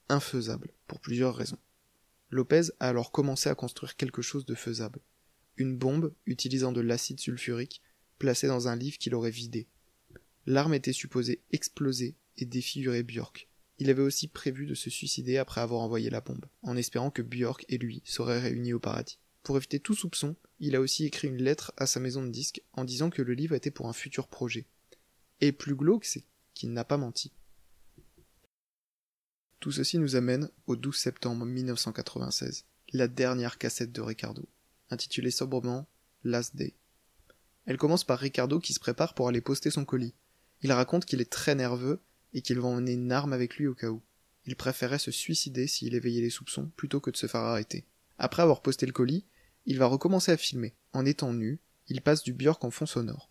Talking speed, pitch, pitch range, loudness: 190 wpm, 130 Hz, 120-140 Hz, -31 LUFS